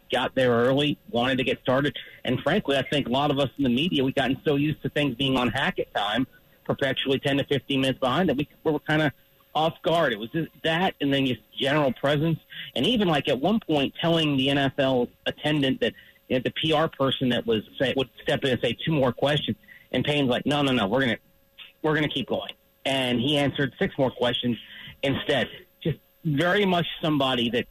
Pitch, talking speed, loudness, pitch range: 140 Hz, 225 wpm, -25 LUFS, 130-150 Hz